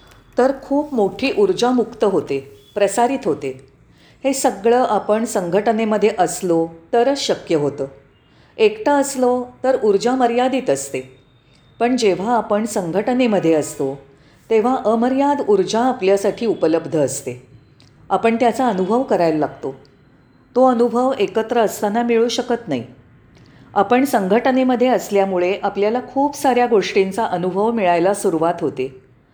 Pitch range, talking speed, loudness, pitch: 155-245 Hz, 115 wpm, -18 LUFS, 210 Hz